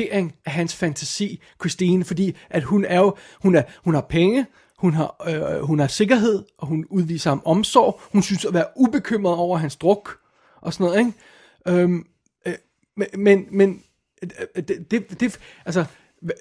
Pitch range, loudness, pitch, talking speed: 165-200 Hz, -21 LUFS, 180 Hz, 170 wpm